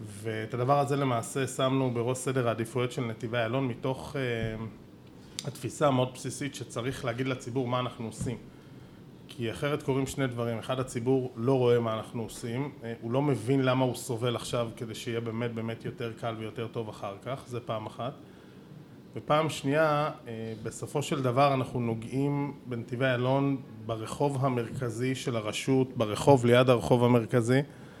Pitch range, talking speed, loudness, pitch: 115-135 Hz, 150 wpm, -30 LUFS, 125 Hz